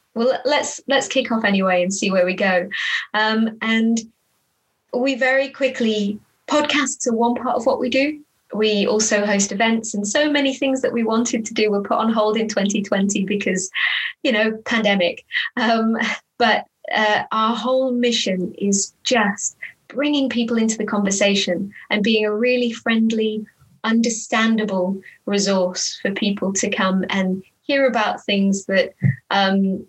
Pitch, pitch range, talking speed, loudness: 220 Hz, 200-245 Hz, 155 wpm, -19 LUFS